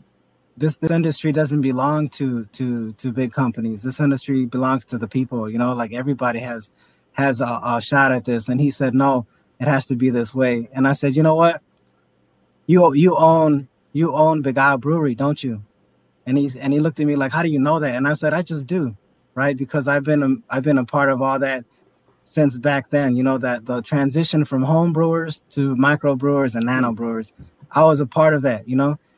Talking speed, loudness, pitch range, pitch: 220 wpm, -19 LUFS, 125-150 Hz, 135 Hz